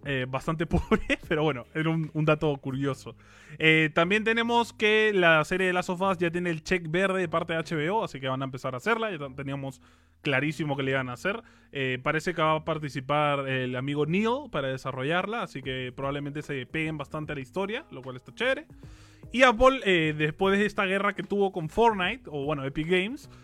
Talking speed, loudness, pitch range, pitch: 210 wpm, -27 LUFS, 135-185 Hz, 155 Hz